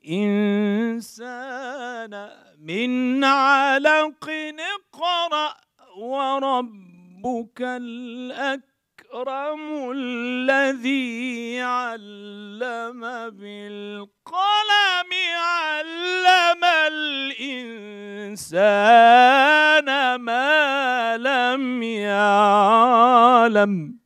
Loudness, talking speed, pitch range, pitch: -19 LUFS, 35 wpm, 225-280 Hz, 250 Hz